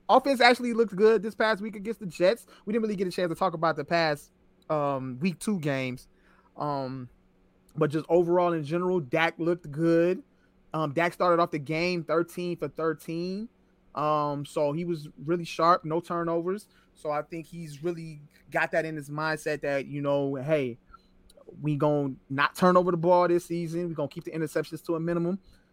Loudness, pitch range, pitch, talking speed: -28 LUFS, 150-180 Hz, 165 Hz, 195 wpm